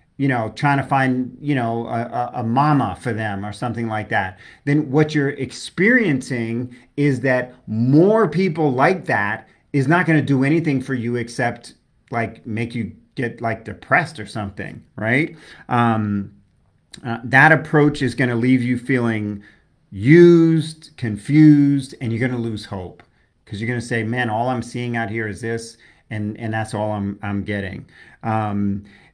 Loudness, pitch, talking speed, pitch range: -19 LUFS, 120 Hz, 170 wpm, 110-140 Hz